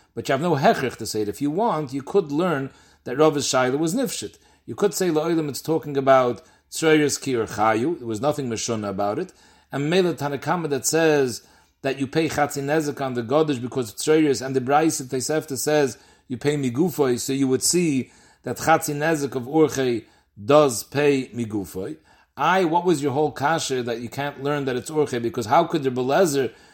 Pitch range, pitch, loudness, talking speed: 130-155 Hz, 140 Hz, -22 LUFS, 195 wpm